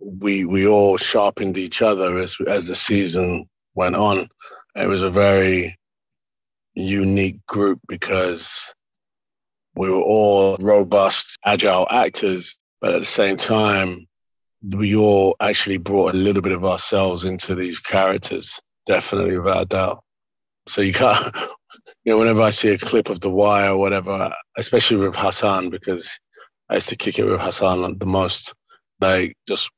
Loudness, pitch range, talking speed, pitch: -19 LUFS, 95-100 Hz, 155 wpm, 95 Hz